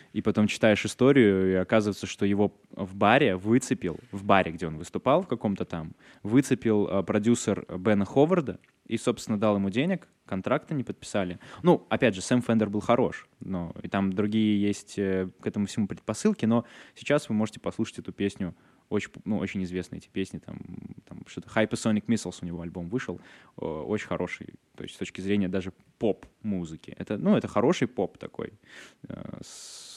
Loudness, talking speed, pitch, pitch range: -27 LUFS, 180 wpm, 100 Hz, 95-110 Hz